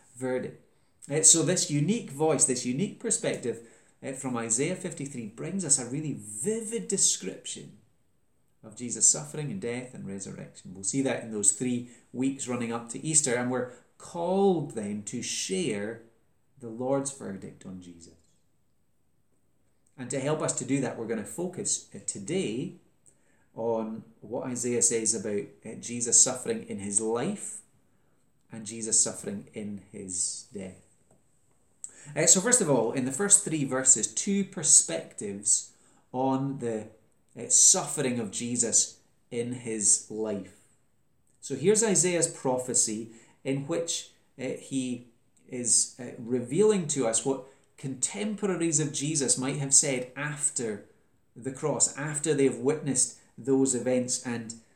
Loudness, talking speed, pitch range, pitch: -26 LUFS, 135 wpm, 115-150 Hz, 125 Hz